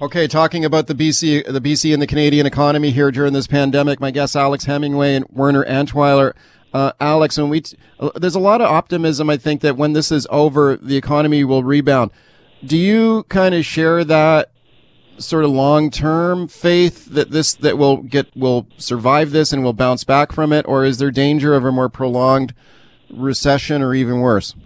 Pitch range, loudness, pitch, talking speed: 135-155 Hz, -15 LUFS, 145 Hz, 195 wpm